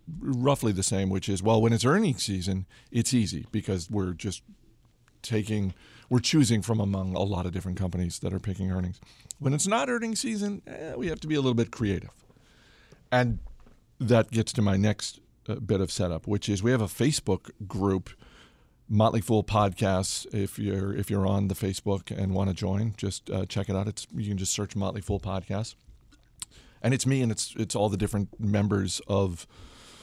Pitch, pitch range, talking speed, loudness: 105 Hz, 95-115 Hz, 195 wpm, -28 LUFS